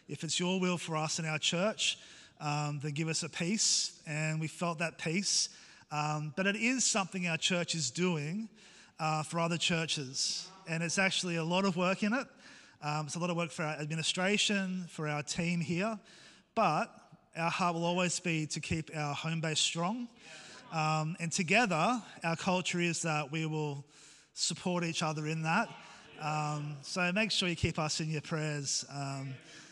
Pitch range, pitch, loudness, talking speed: 155-185 Hz, 165 Hz, -33 LUFS, 185 wpm